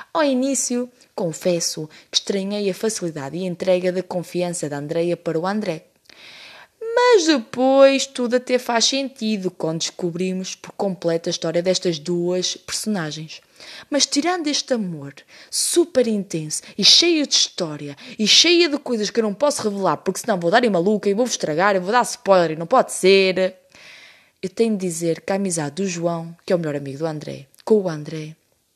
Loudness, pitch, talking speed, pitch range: -19 LUFS, 190 Hz, 180 wpm, 170-245 Hz